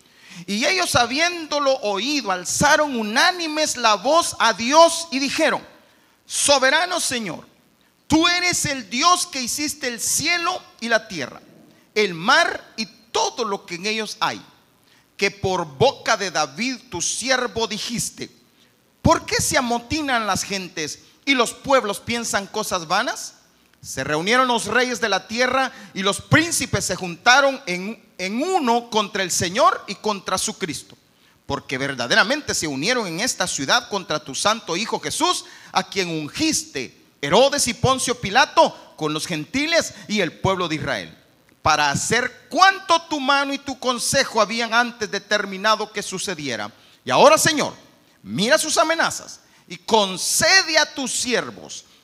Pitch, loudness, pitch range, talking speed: 230 Hz, -20 LUFS, 195-285 Hz, 145 wpm